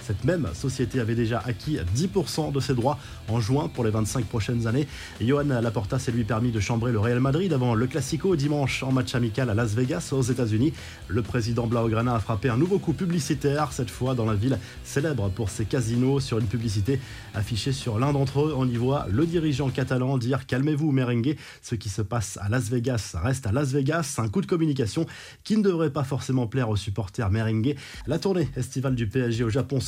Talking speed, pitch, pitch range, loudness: 215 wpm, 130 Hz, 115-145 Hz, -26 LUFS